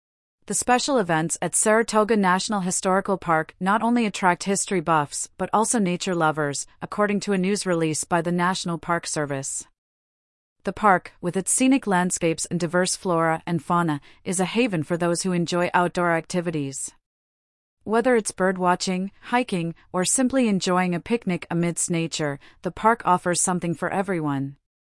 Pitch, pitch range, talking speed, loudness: 180 Hz, 165-195 Hz, 155 wpm, -23 LUFS